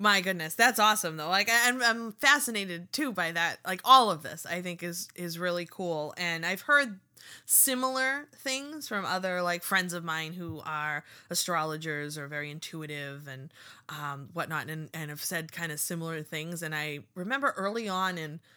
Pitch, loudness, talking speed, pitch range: 175 Hz, -29 LUFS, 180 wpm, 155-205 Hz